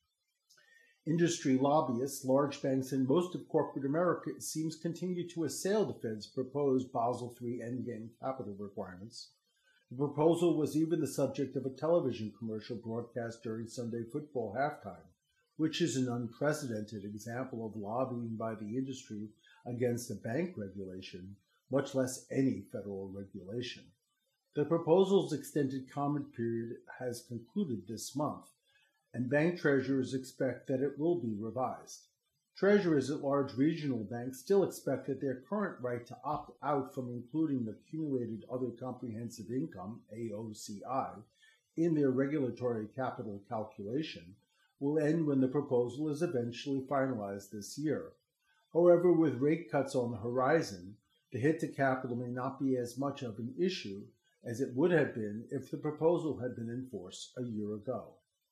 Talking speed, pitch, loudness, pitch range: 150 wpm, 130 Hz, -35 LUFS, 115-150 Hz